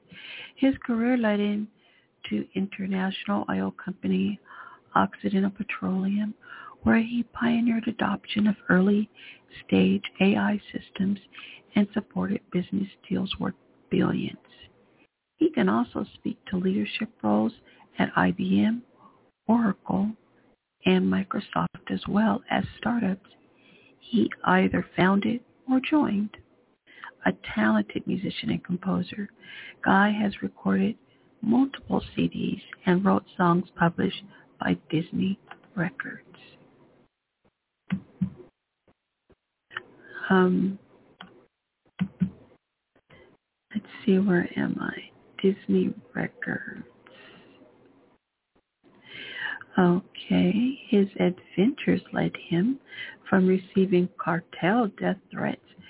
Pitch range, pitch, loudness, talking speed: 185-220 Hz, 200 Hz, -26 LUFS, 85 wpm